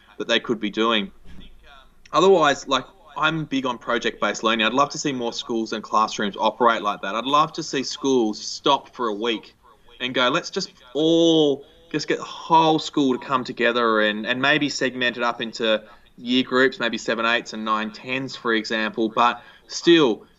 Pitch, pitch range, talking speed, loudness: 125 Hz, 115-140 Hz, 190 wpm, -21 LUFS